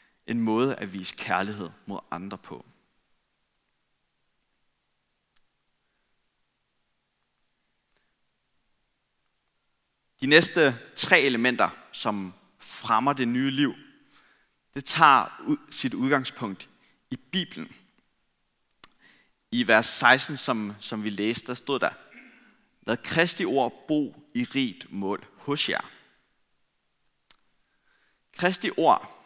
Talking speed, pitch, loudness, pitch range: 90 wpm, 130 Hz, -25 LUFS, 110-160 Hz